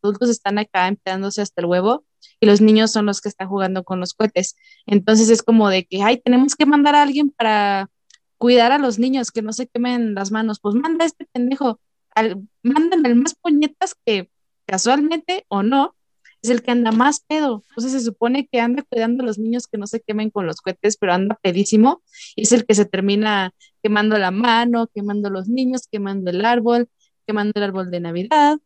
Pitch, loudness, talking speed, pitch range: 225 Hz, -18 LUFS, 205 wpm, 205-255 Hz